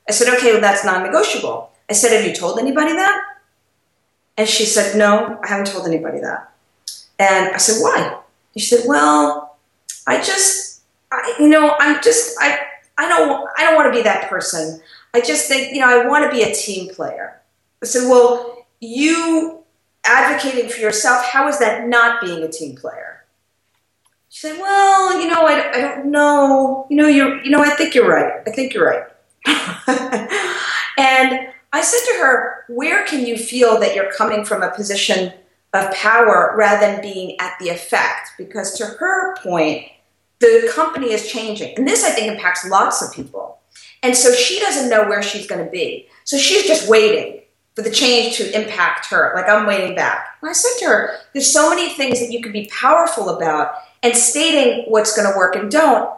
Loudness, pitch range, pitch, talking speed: -15 LUFS, 205-300 Hz, 240 Hz, 195 wpm